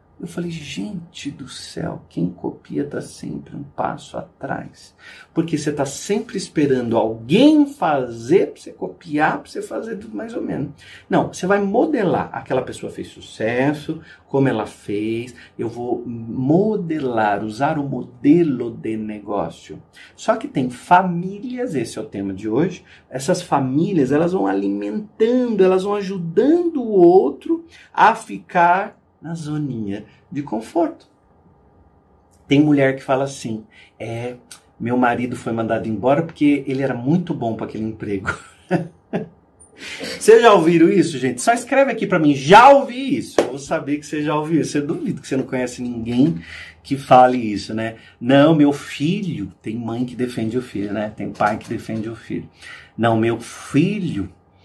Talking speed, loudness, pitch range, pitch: 155 wpm, -19 LUFS, 110-170 Hz, 135 Hz